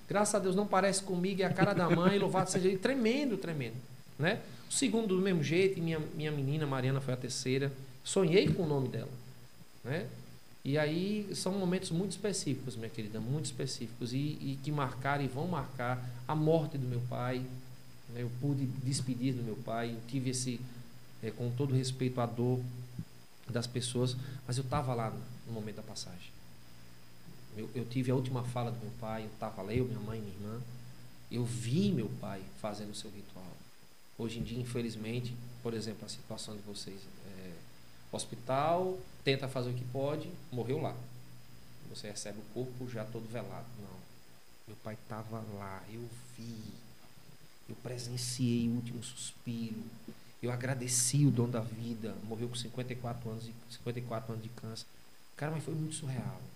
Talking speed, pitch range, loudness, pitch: 175 wpm, 110-140 Hz, -35 LUFS, 125 Hz